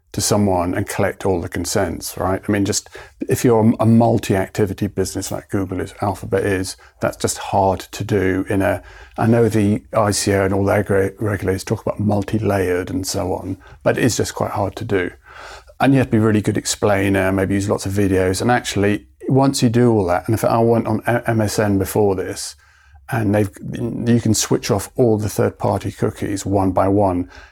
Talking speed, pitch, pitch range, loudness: 205 wpm, 105 Hz, 95-115 Hz, -18 LUFS